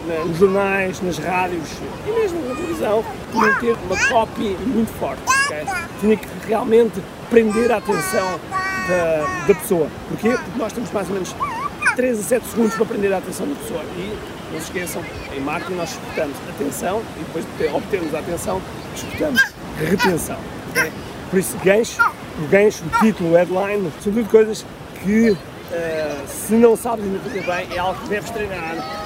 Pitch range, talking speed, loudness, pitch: 185-230 Hz, 165 wpm, -20 LUFS, 205 Hz